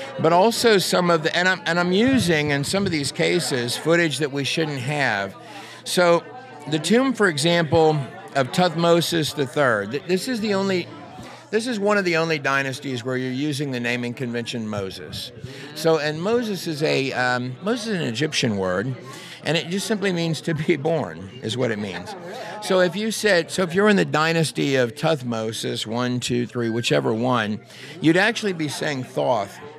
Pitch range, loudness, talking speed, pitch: 130-180 Hz, -21 LUFS, 185 wpm, 155 Hz